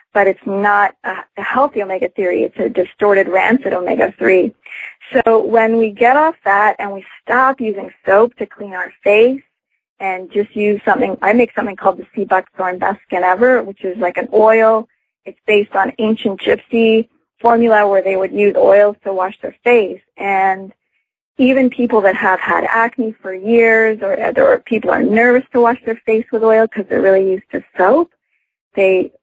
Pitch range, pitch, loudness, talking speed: 195-235 Hz, 215 Hz, -14 LUFS, 185 wpm